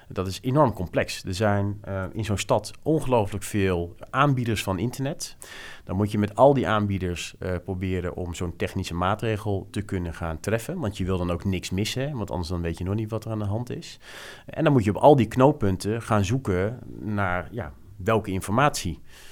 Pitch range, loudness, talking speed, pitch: 95-115 Hz, -25 LUFS, 205 wpm, 100 Hz